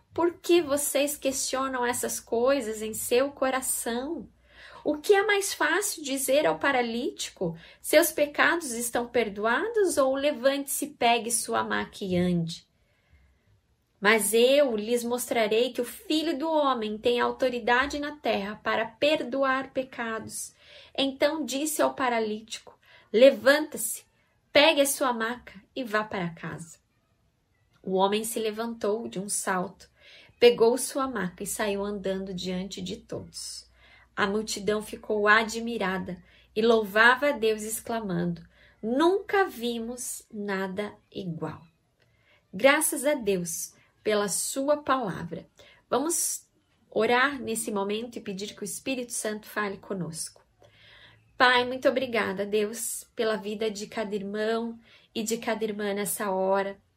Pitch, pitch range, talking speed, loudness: 225 Hz, 195-265 Hz, 125 wpm, -27 LUFS